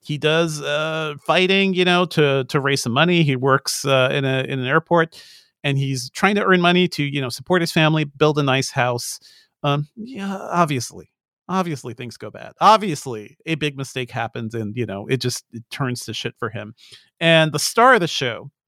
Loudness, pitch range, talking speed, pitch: -19 LUFS, 130-165 Hz, 205 wpm, 145 Hz